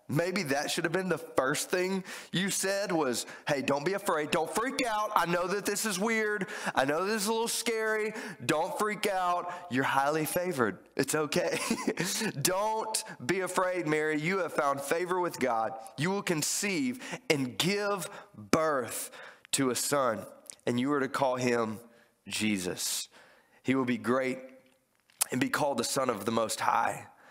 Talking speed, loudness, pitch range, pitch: 170 wpm, -30 LUFS, 135-205 Hz, 175 Hz